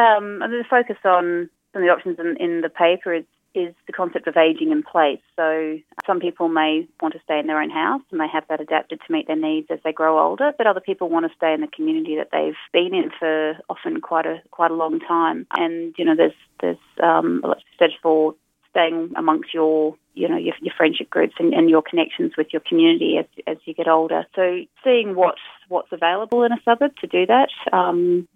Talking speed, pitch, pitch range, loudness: 235 wpm, 170 Hz, 160-200 Hz, -20 LUFS